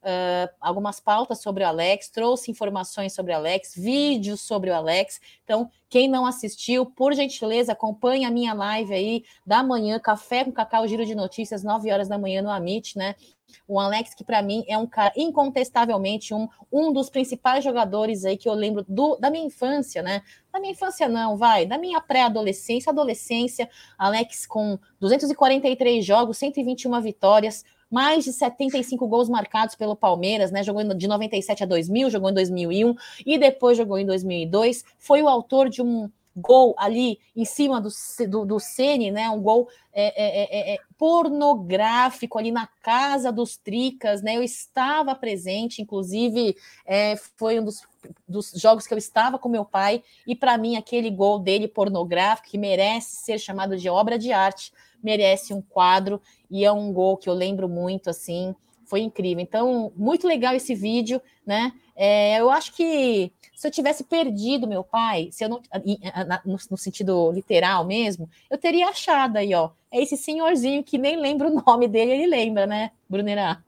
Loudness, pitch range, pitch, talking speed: -23 LUFS, 200-255 Hz, 225 Hz, 175 wpm